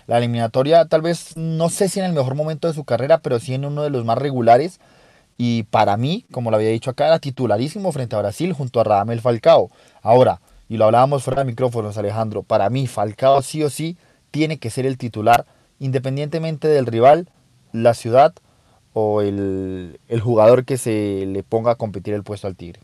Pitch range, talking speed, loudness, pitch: 110-150 Hz, 200 wpm, -18 LUFS, 125 Hz